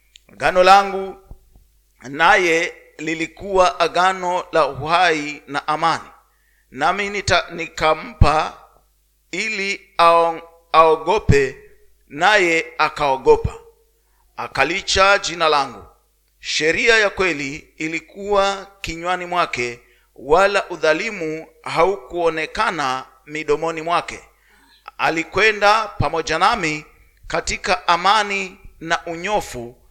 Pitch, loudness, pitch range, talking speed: 170 Hz, -18 LUFS, 155-200 Hz, 70 wpm